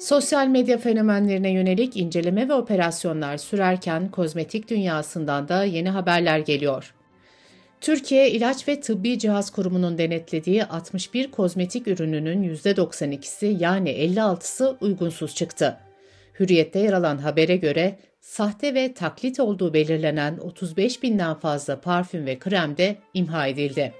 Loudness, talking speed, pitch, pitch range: -23 LUFS, 120 wpm, 180 Hz, 160-210 Hz